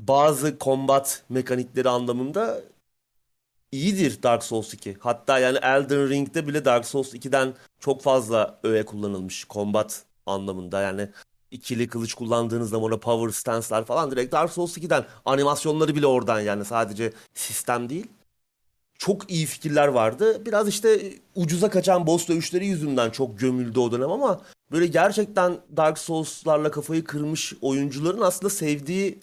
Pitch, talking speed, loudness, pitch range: 135 Hz, 140 wpm, -24 LUFS, 115-160 Hz